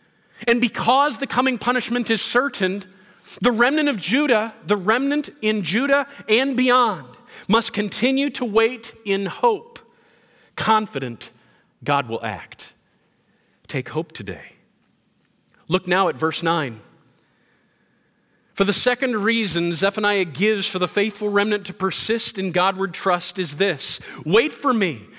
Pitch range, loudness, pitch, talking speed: 180-240 Hz, -20 LUFS, 205 Hz, 130 wpm